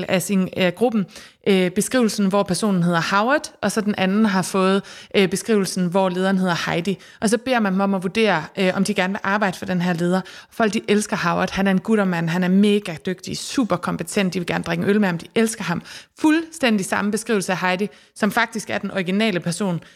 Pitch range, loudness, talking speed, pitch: 185-215 Hz, -20 LUFS, 230 wpm, 195 Hz